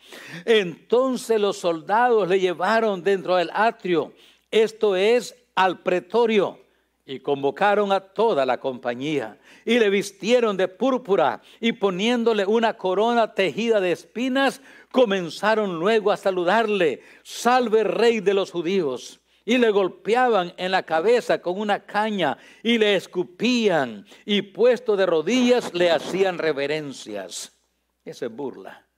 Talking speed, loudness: 125 wpm, -22 LUFS